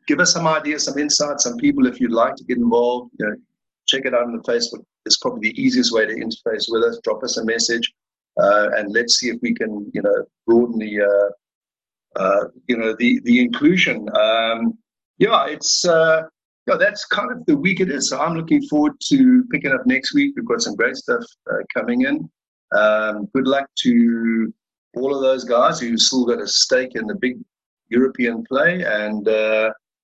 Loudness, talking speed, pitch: -18 LUFS, 210 wpm, 160 Hz